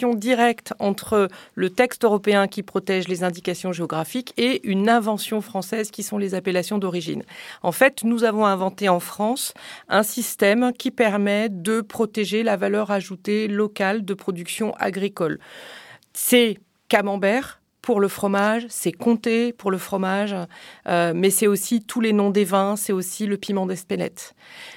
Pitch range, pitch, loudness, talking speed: 195-225 Hz, 205 Hz, -22 LUFS, 155 wpm